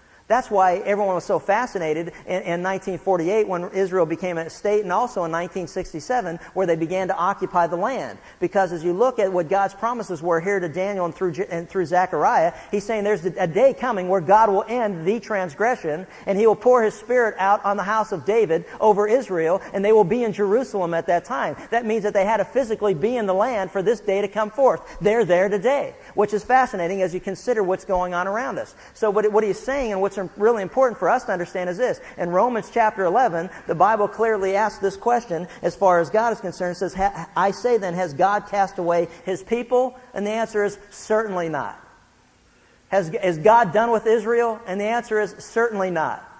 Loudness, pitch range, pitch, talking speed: -21 LUFS, 180-220 Hz, 200 Hz, 215 wpm